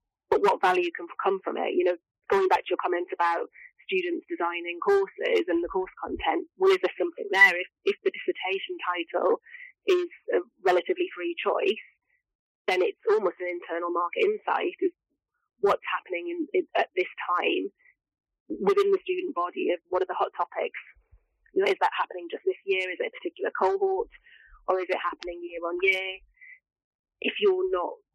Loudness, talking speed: -27 LUFS, 180 wpm